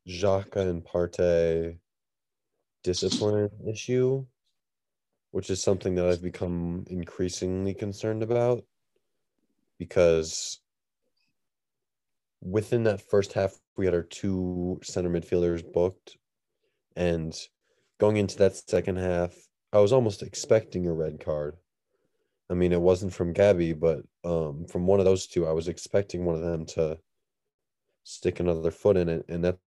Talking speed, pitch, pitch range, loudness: 135 wpm, 90 Hz, 85-100 Hz, -27 LUFS